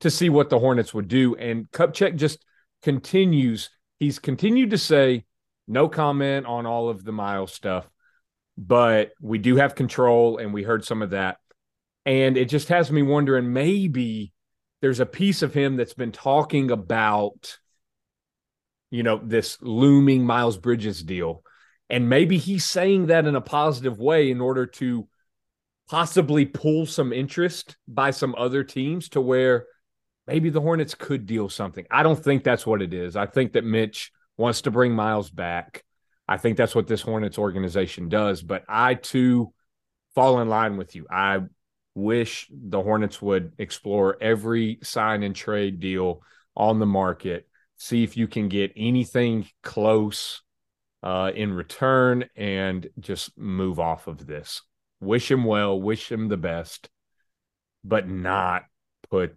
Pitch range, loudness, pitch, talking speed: 105-135 Hz, -23 LUFS, 115 Hz, 160 wpm